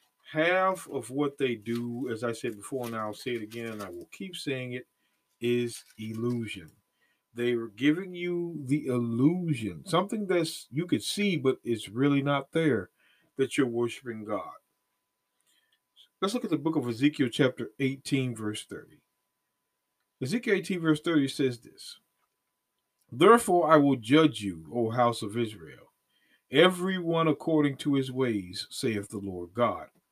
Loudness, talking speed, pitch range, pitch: -28 LUFS, 155 wpm, 115-160 Hz, 135 Hz